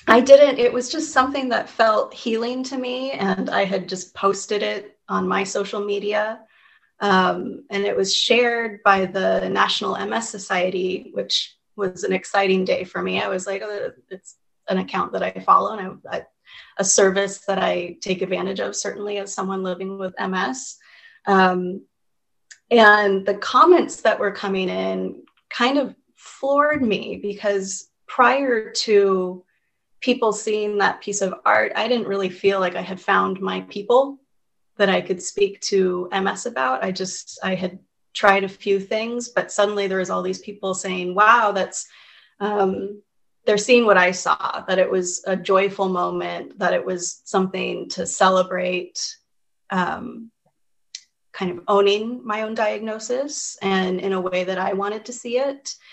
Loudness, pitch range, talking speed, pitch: -21 LUFS, 190-230 Hz, 165 wpm, 200 Hz